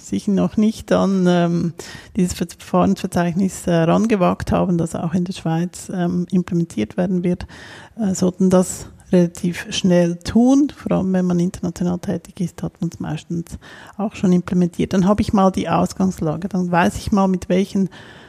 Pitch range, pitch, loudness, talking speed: 175-195 Hz, 180 Hz, -19 LUFS, 155 wpm